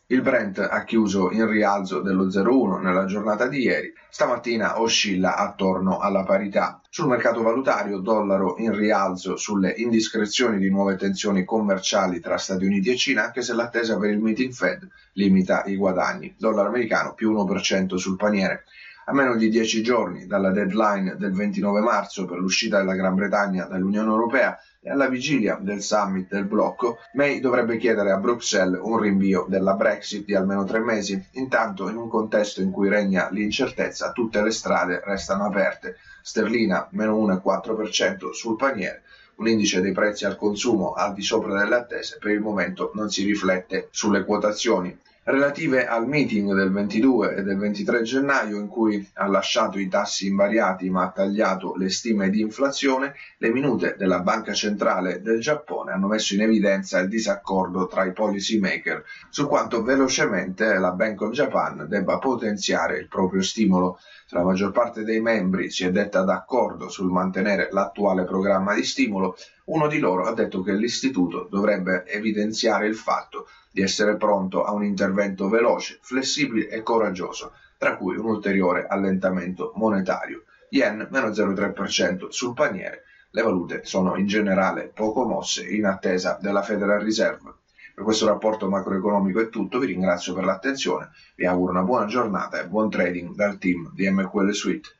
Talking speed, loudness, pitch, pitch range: 165 wpm, -23 LUFS, 105 Hz, 95-110 Hz